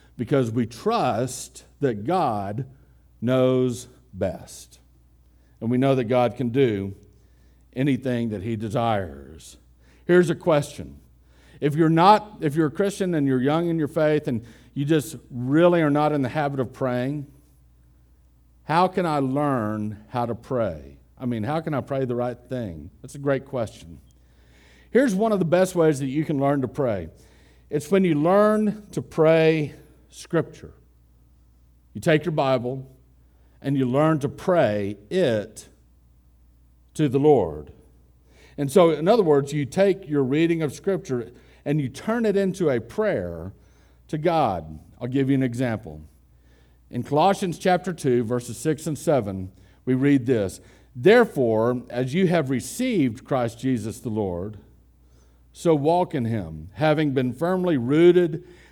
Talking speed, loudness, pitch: 155 wpm, -23 LUFS, 125 Hz